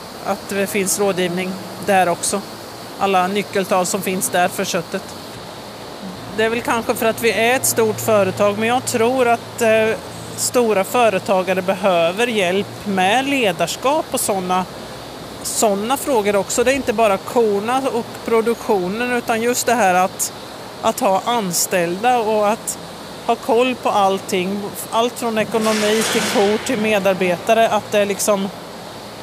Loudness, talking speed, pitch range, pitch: -18 LUFS, 150 wpm, 195-235 Hz, 210 Hz